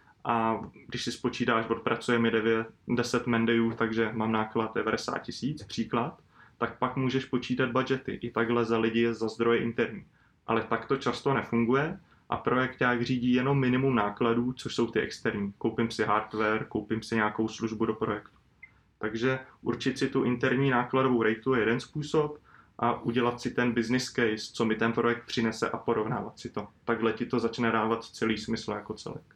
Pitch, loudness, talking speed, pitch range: 115 Hz, -29 LUFS, 180 wpm, 115-125 Hz